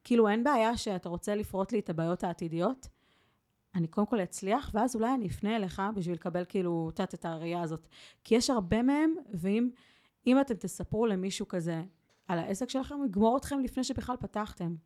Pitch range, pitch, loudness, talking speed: 180-235 Hz, 205 Hz, -32 LUFS, 180 wpm